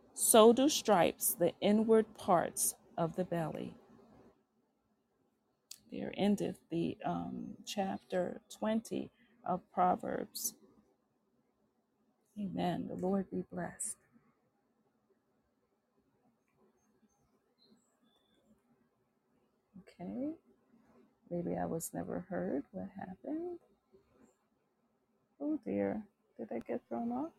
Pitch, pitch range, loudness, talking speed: 210 Hz, 185-235 Hz, -35 LUFS, 80 wpm